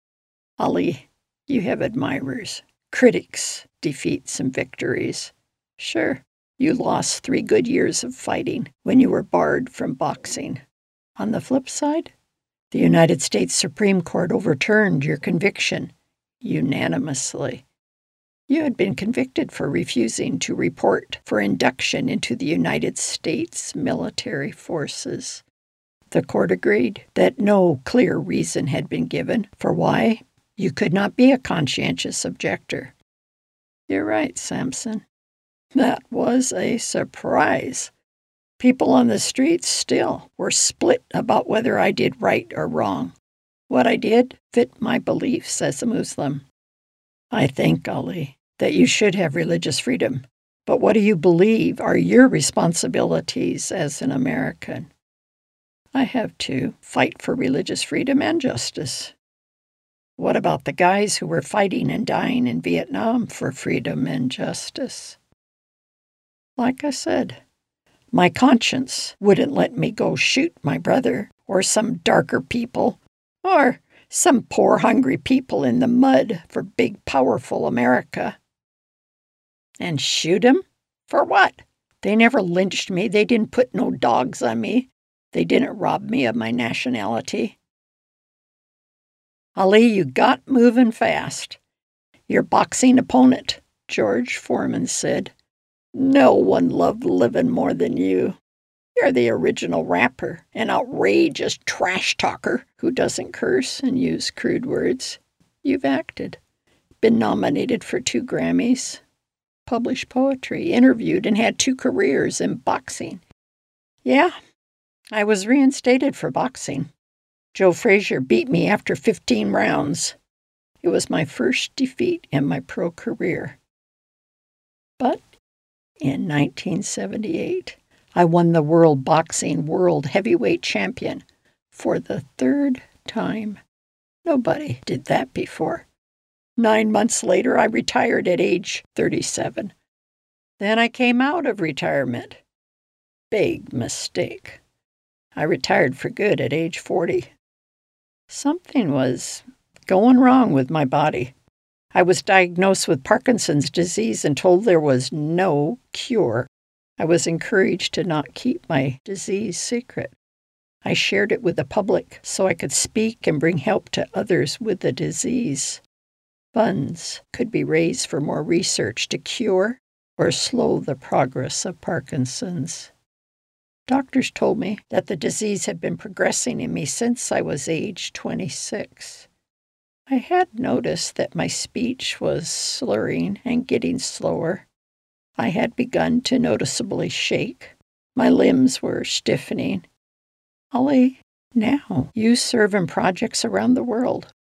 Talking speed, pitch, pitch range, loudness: 130 wpm, 225 Hz, 180-255 Hz, -20 LUFS